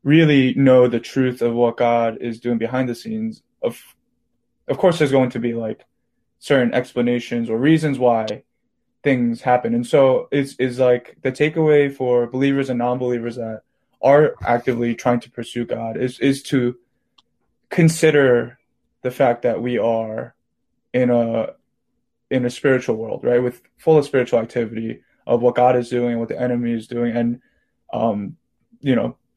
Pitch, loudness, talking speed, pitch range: 125 Hz, -19 LUFS, 165 wpm, 120-135 Hz